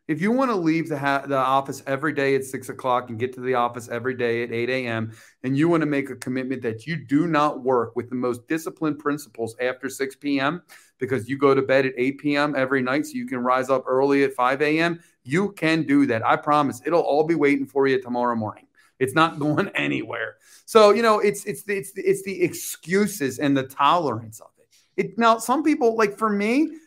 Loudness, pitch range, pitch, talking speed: -22 LUFS, 130-170 Hz, 140 Hz, 230 wpm